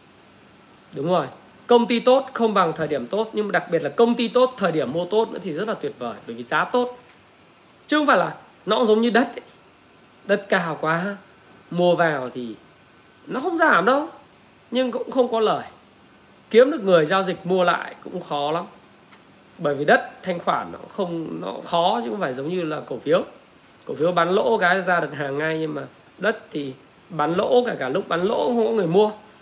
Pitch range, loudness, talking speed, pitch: 160-235 Hz, -22 LUFS, 220 wpm, 190 Hz